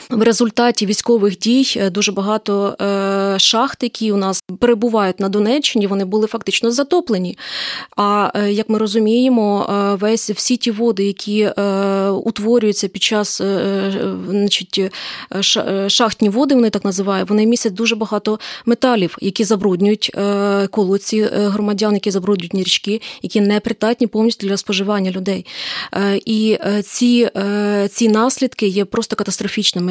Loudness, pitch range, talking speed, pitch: -16 LUFS, 200-225 Hz, 120 wpm, 210 Hz